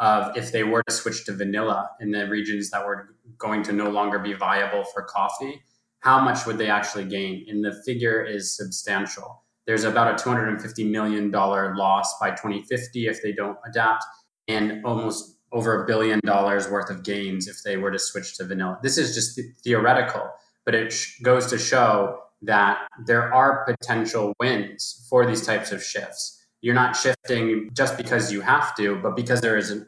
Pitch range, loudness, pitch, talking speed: 100-120 Hz, -23 LUFS, 110 Hz, 190 wpm